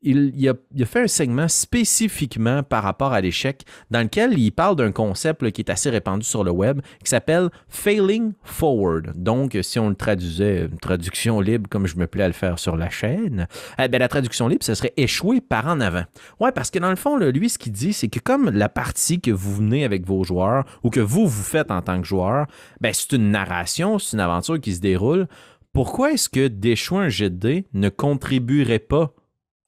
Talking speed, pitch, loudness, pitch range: 220 wpm, 120 Hz, -21 LUFS, 100-155 Hz